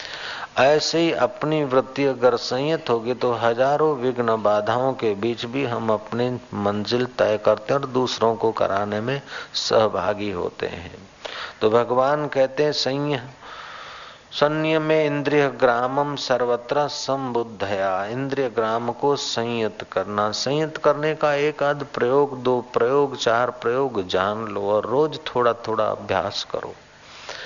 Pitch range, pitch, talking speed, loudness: 115-145 Hz, 125 Hz, 130 wpm, -22 LUFS